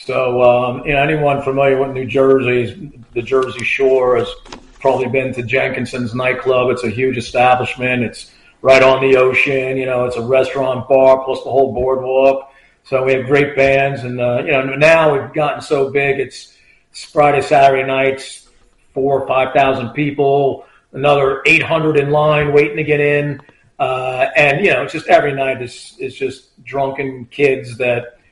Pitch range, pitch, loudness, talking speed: 130-140 Hz, 135 Hz, -14 LUFS, 175 wpm